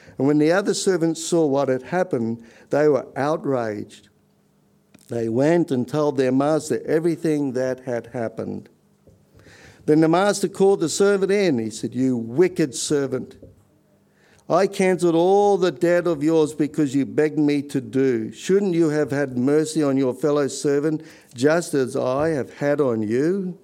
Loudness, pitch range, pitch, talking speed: -21 LUFS, 130-170 Hz, 150 Hz, 160 wpm